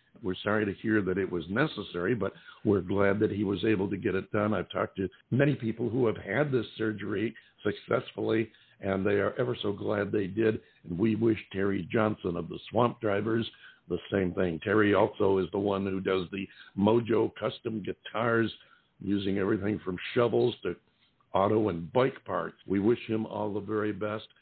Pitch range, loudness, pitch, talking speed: 100-110 Hz, -30 LUFS, 105 Hz, 190 wpm